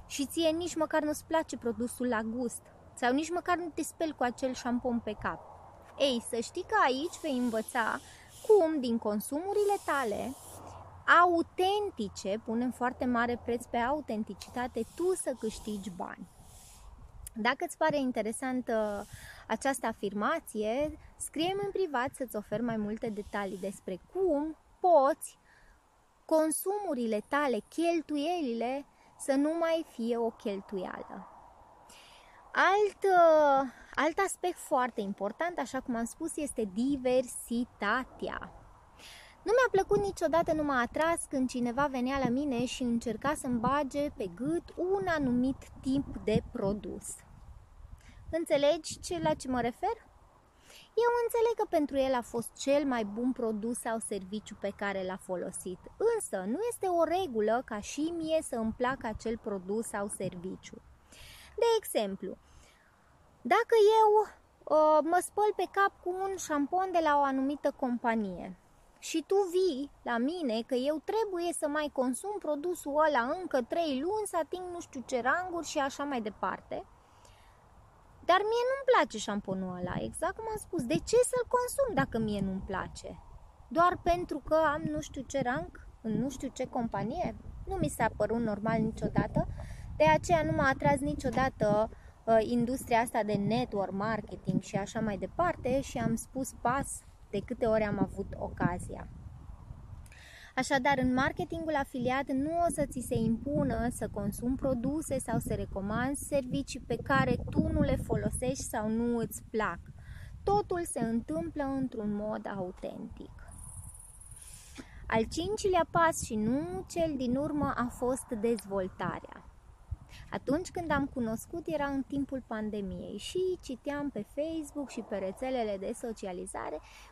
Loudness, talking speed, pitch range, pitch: -32 LUFS, 145 wpm, 225-325 Hz, 265 Hz